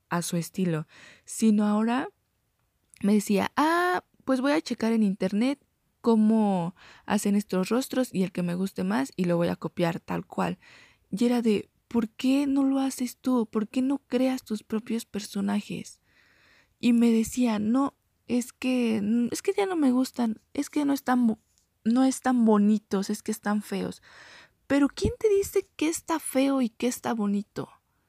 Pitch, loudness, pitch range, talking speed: 230 Hz, -27 LUFS, 205-265 Hz, 175 wpm